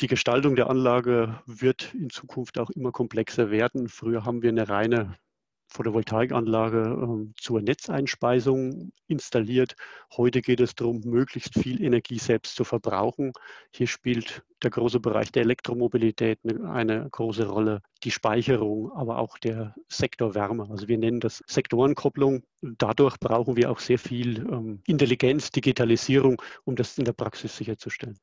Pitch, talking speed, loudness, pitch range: 120 Hz, 140 wpm, -26 LUFS, 115-125 Hz